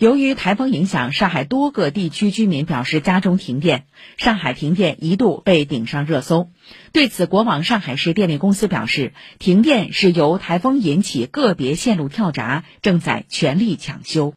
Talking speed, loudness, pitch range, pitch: 265 characters per minute, -18 LUFS, 155-215 Hz, 185 Hz